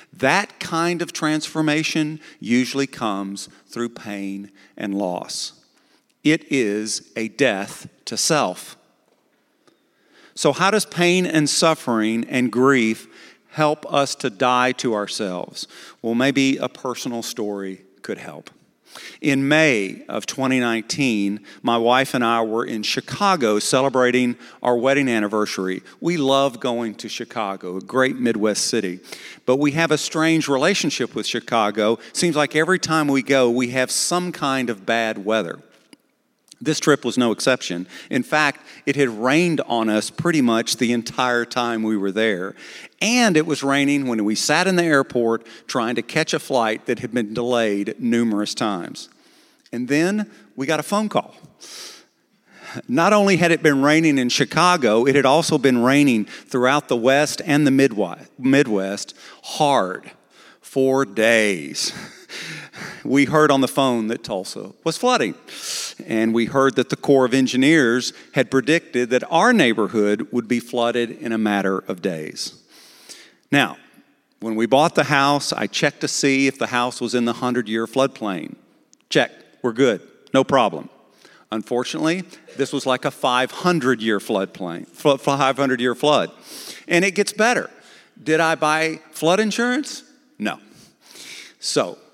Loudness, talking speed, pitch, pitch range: -20 LUFS, 145 wpm, 130 Hz, 115-155 Hz